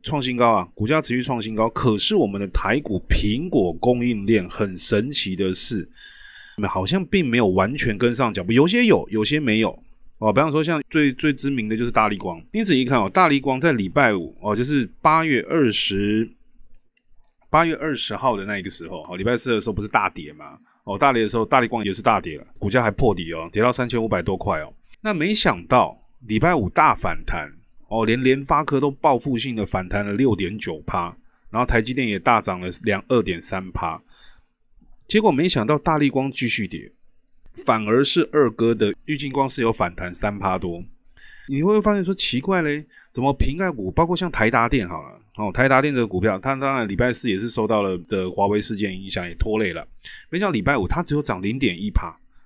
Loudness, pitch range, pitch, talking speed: -21 LUFS, 105-140 Hz, 120 Hz, 300 characters per minute